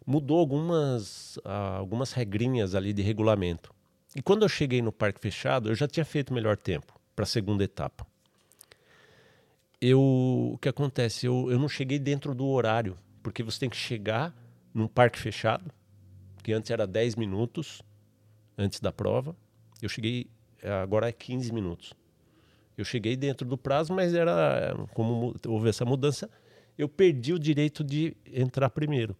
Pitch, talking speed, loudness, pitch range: 120 Hz, 155 wpm, -29 LUFS, 105-140 Hz